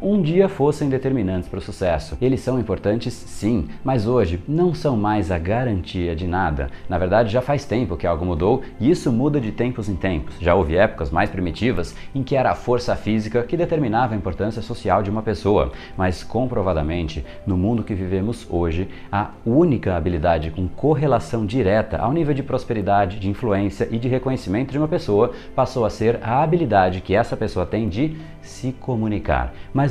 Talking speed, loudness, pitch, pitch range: 185 wpm, -21 LUFS, 105 Hz, 90-130 Hz